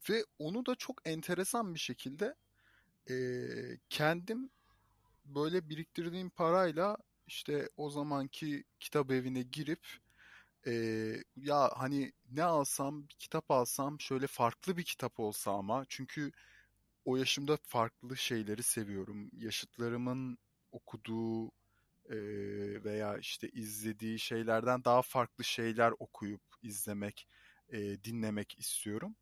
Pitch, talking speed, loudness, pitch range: 125 Hz, 110 wpm, -37 LUFS, 110-150 Hz